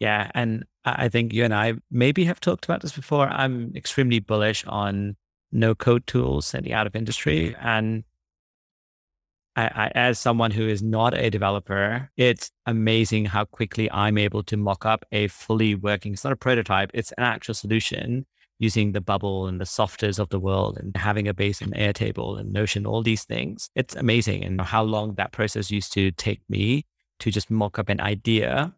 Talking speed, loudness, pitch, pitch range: 190 wpm, -24 LUFS, 110 Hz, 100-115 Hz